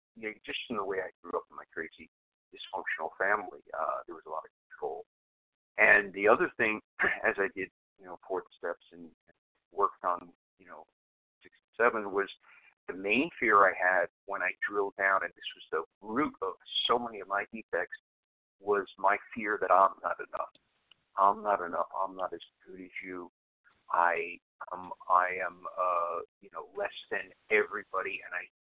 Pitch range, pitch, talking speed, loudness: 90-110 Hz, 95 Hz, 185 wpm, -31 LUFS